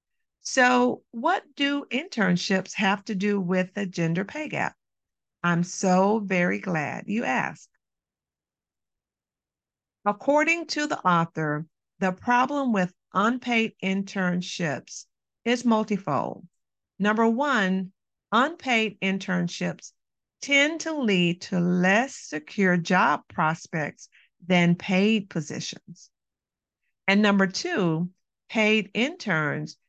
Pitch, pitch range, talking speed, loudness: 195 Hz, 180-230 Hz, 100 wpm, -25 LUFS